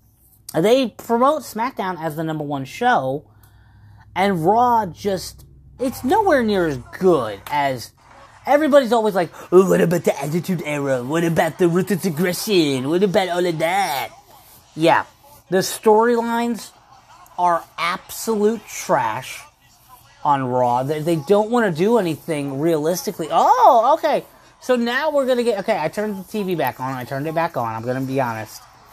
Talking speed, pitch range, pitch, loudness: 155 wpm, 140-220 Hz, 175 Hz, -19 LUFS